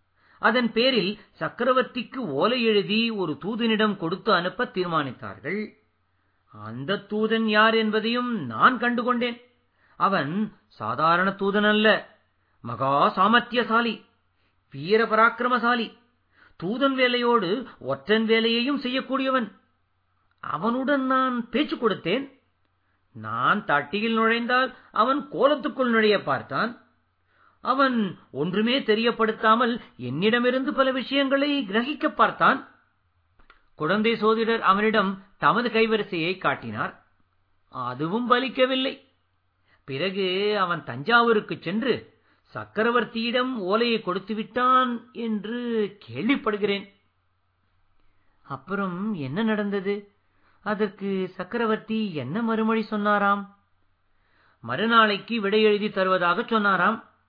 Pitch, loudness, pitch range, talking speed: 215 Hz, -24 LUFS, 165-235 Hz, 80 wpm